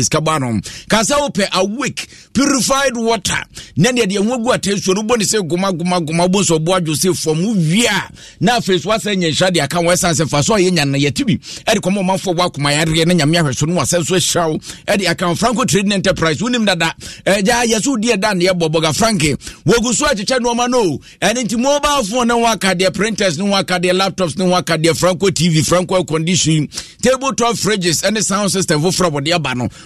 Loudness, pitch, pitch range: -15 LUFS, 185 Hz, 170-220 Hz